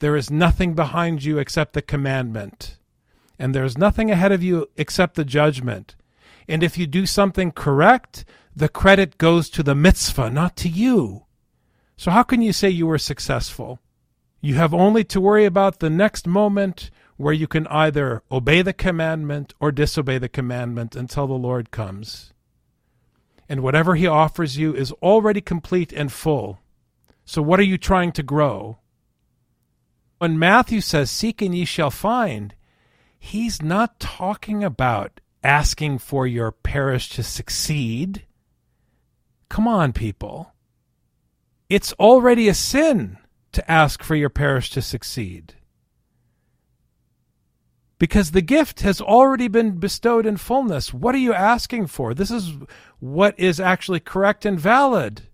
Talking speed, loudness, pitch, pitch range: 145 wpm, -19 LUFS, 160 Hz, 135-195 Hz